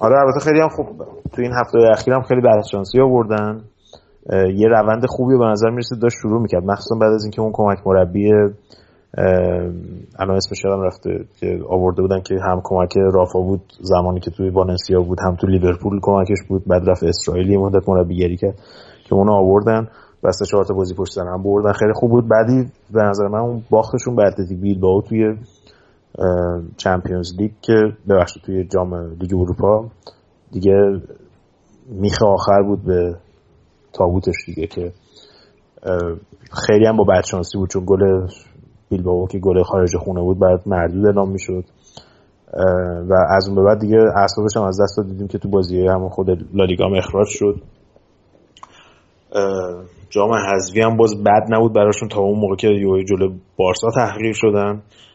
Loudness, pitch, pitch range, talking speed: -17 LUFS, 100 Hz, 95-110 Hz, 165 wpm